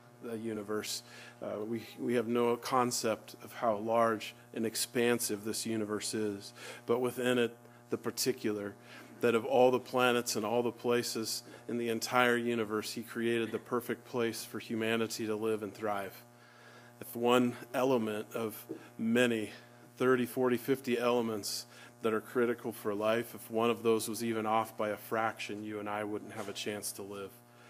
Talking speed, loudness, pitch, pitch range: 170 wpm, -33 LUFS, 115 Hz, 110-120 Hz